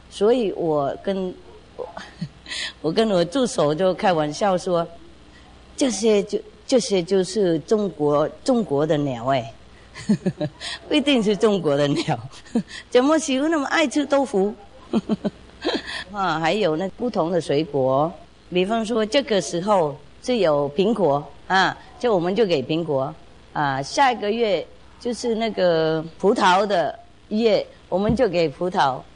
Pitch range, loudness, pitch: 155-230 Hz, -22 LUFS, 190 Hz